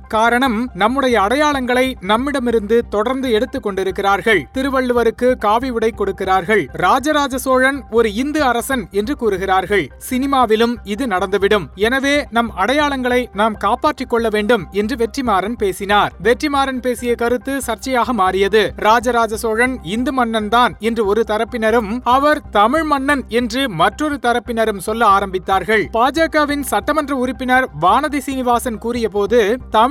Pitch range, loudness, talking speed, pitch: 215-260 Hz, -16 LUFS, 115 wpm, 235 Hz